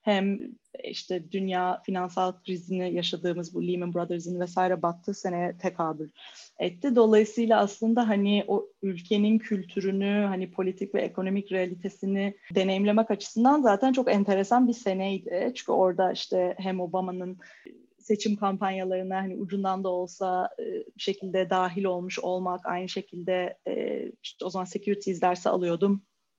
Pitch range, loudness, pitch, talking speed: 185-205 Hz, -28 LUFS, 195 Hz, 125 wpm